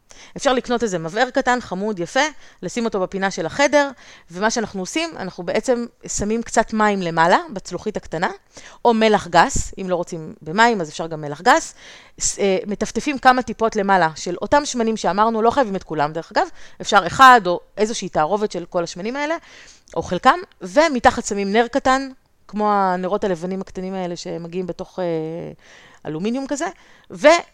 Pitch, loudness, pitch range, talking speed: 210 Hz, -19 LUFS, 180-245 Hz, 160 wpm